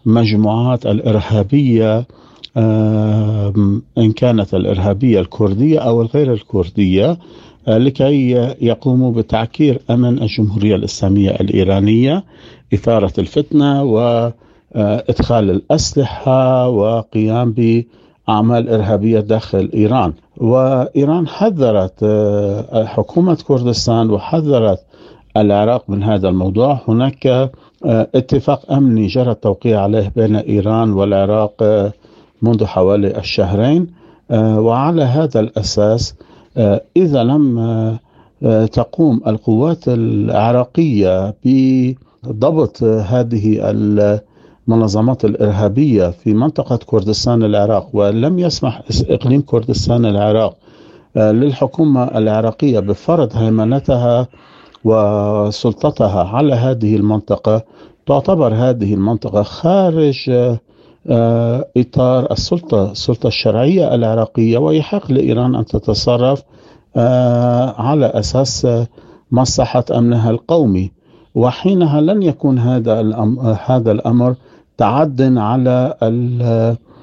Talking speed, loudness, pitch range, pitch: 80 wpm, -14 LUFS, 105-130 Hz, 115 Hz